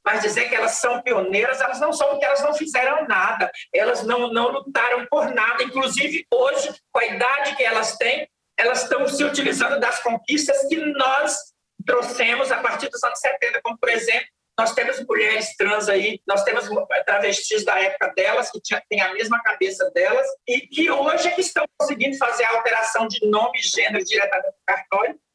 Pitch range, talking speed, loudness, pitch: 230-295 Hz, 190 wpm, -20 LUFS, 260 Hz